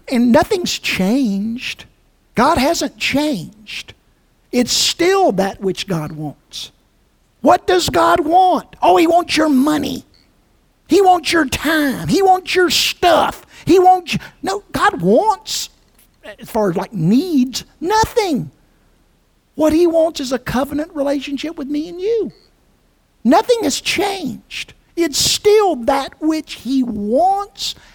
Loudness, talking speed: -16 LUFS, 130 wpm